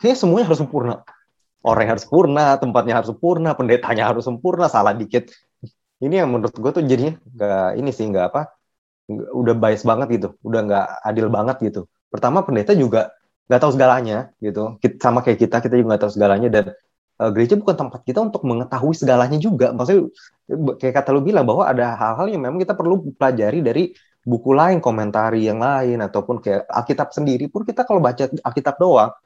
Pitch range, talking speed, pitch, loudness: 115-150 Hz, 185 wpm, 125 Hz, -18 LUFS